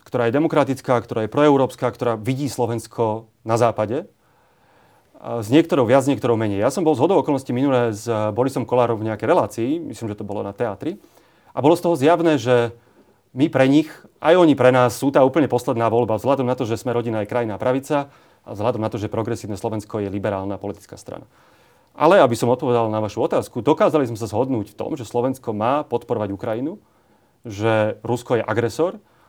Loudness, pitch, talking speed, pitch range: -20 LUFS, 120 Hz, 200 wpm, 110-135 Hz